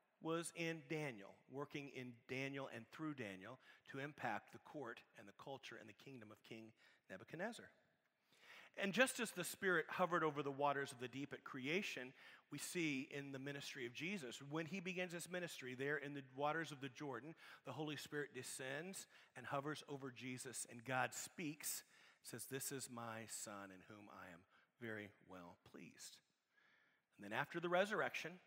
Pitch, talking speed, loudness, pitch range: 140 Hz, 175 wpm, -47 LUFS, 125-160 Hz